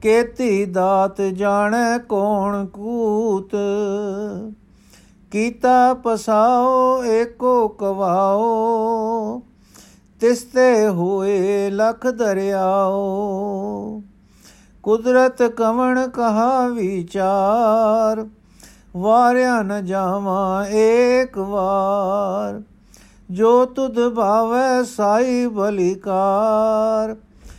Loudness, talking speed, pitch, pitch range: -18 LUFS, 60 wpm, 215 Hz, 195-235 Hz